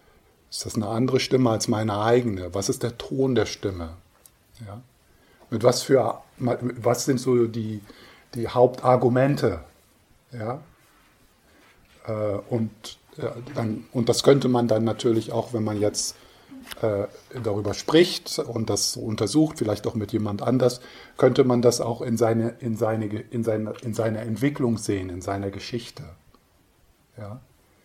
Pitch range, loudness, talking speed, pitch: 110-125 Hz, -24 LUFS, 140 wpm, 115 Hz